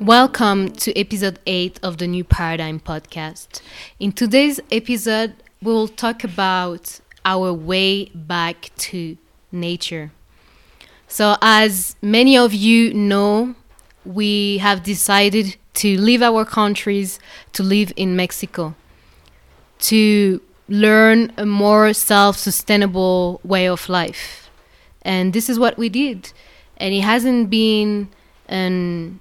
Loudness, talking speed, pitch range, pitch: -16 LUFS, 120 wpm, 180-220 Hz, 200 Hz